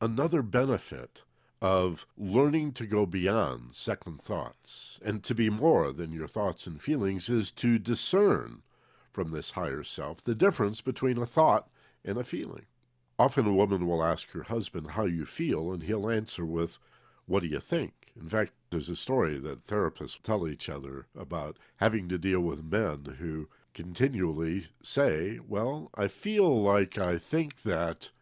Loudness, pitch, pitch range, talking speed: -30 LUFS, 100 Hz, 85-115 Hz, 165 wpm